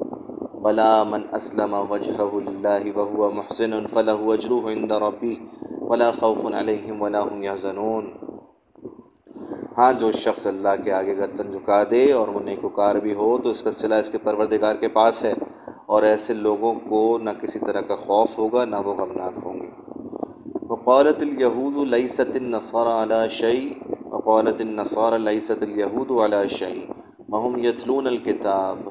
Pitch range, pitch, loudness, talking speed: 105-115 Hz, 110 Hz, -22 LUFS, 145 wpm